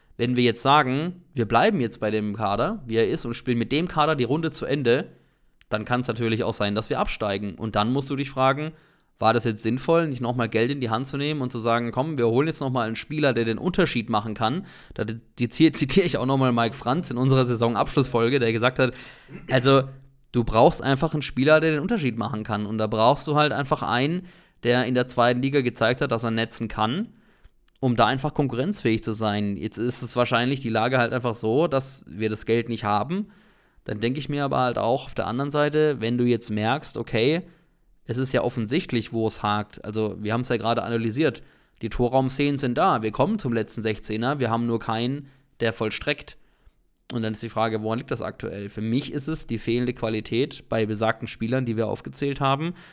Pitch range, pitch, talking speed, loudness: 115-140 Hz, 120 Hz, 220 wpm, -24 LUFS